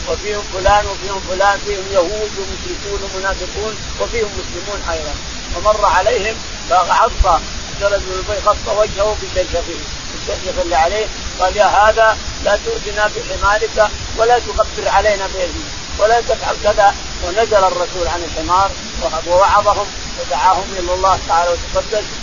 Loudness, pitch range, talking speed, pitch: -16 LUFS, 185-210 Hz, 115 wpm, 200 Hz